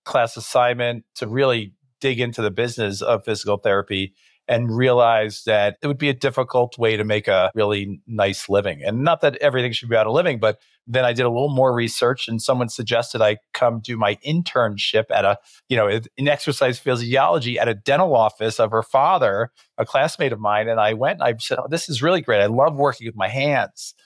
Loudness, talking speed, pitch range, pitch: -20 LUFS, 215 wpm, 110-130 Hz, 120 Hz